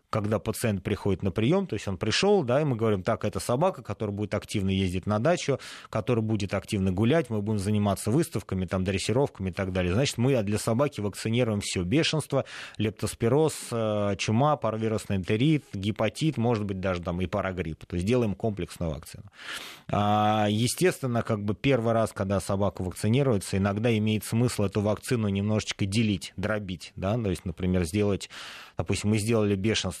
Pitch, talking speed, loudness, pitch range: 105 Hz, 165 wpm, -27 LUFS, 100-120 Hz